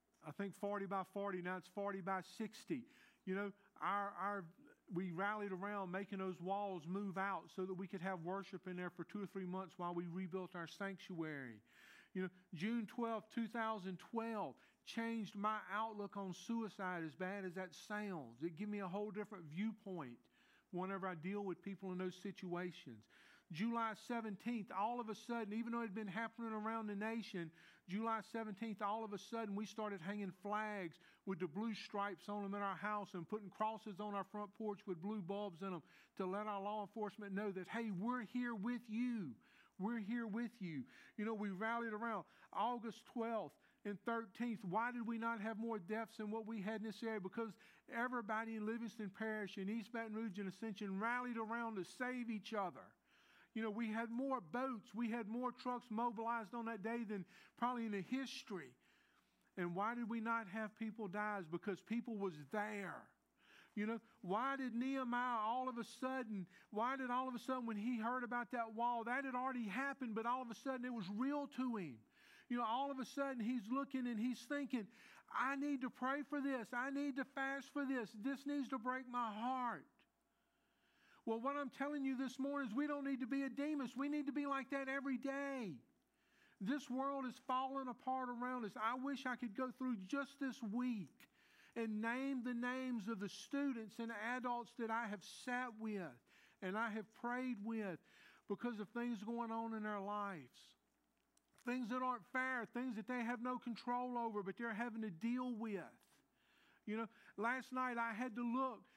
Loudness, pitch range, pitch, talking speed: -45 LUFS, 200-245 Hz, 225 Hz, 200 wpm